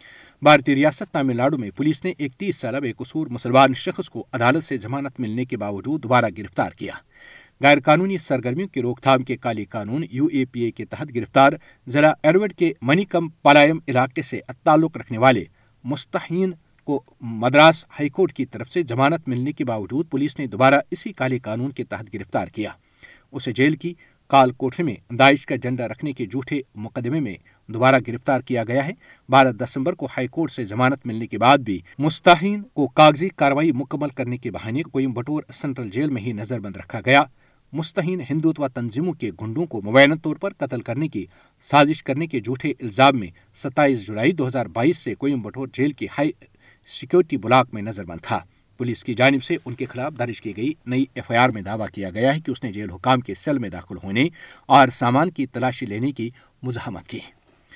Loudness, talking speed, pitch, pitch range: -21 LUFS, 200 wpm, 135 Hz, 120-150 Hz